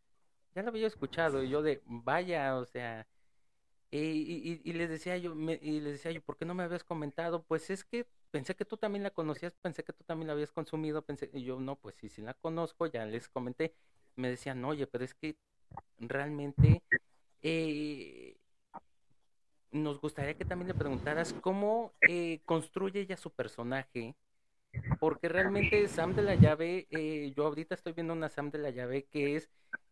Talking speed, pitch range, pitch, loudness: 185 wpm, 135-170 Hz, 155 Hz, -35 LUFS